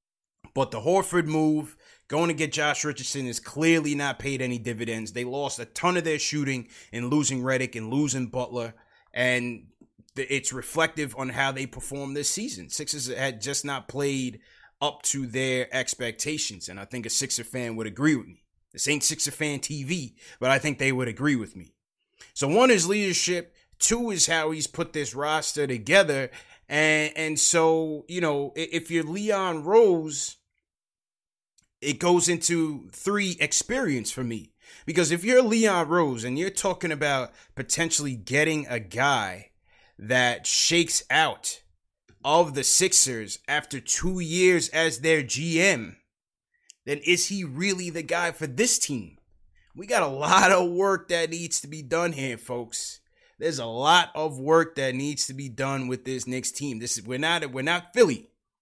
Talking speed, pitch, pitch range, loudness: 170 wpm, 145 Hz, 130-165 Hz, -25 LUFS